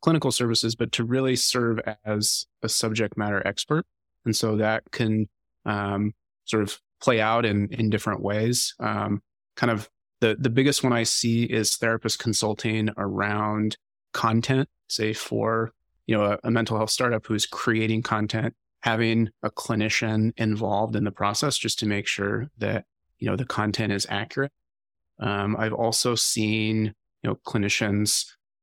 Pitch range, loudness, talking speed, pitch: 105-115 Hz, -25 LUFS, 155 wpm, 110 Hz